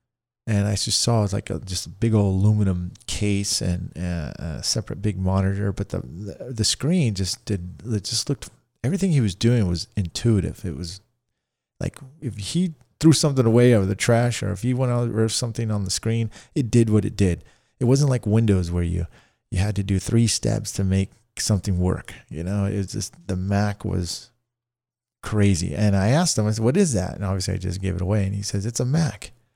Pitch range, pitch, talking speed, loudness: 95-120 Hz, 105 Hz, 220 wpm, -23 LUFS